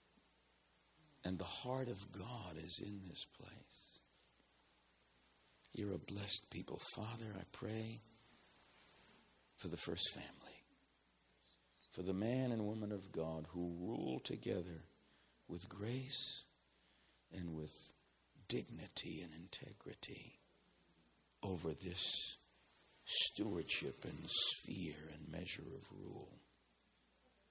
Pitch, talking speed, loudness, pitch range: 90 Hz, 100 wpm, -43 LUFS, 70-105 Hz